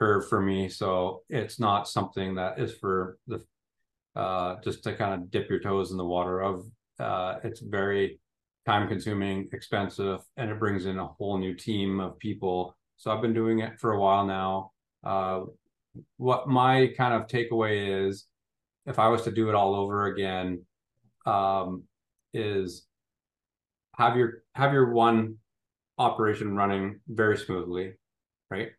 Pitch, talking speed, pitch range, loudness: 100 Hz, 160 wpm, 95-115 Hz, -28 LUFS